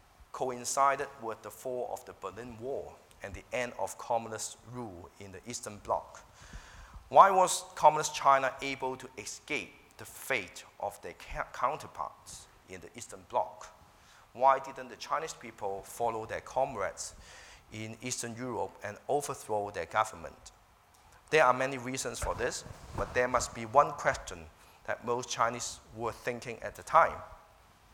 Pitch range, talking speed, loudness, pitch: 110-130 Hz, 150 wpm, -32 LUFS, 120 Hz